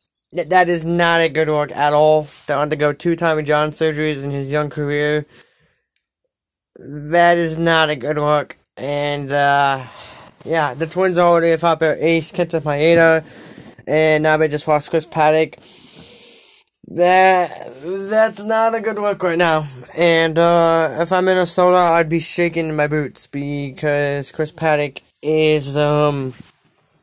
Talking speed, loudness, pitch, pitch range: 150 wpm, -16 LUFS, 155 Hz, 150-170 Hz